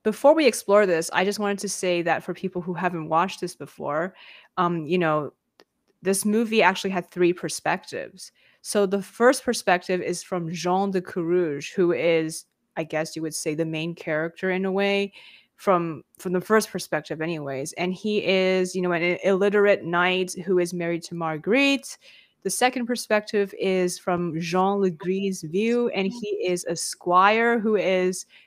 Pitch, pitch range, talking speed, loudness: 185 Hz, 170-200 Hz, 175 wpm, -24 LUFS